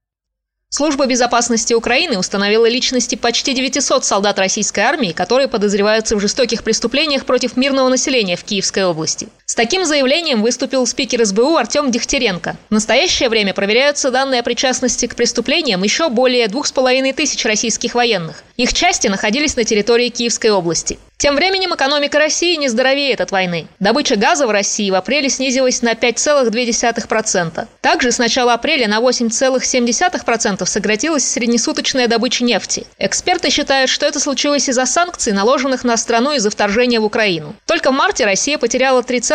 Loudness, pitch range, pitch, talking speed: -14 LUFS, 225-275 Hz, 245 Hz, 150 wpm